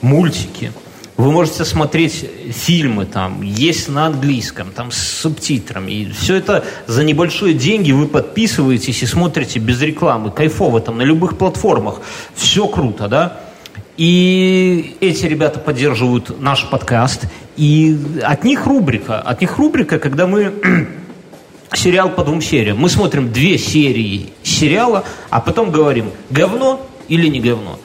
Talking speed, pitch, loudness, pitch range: 135 wpm, 150 Hz, -14 LUFS, 120-175 Hz